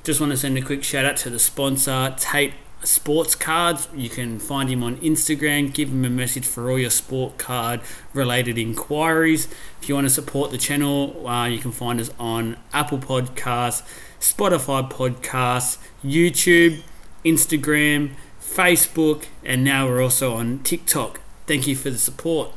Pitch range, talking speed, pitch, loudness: 125-150 Hz, 165 wpm, 135 Hz, -19 LUFS